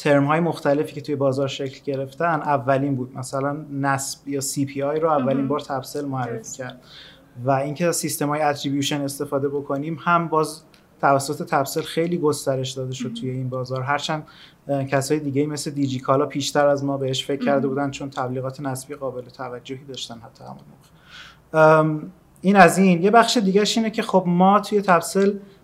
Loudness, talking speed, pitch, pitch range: -21 LUFS, 175 wpm, 145 Hz, 135-155 Hz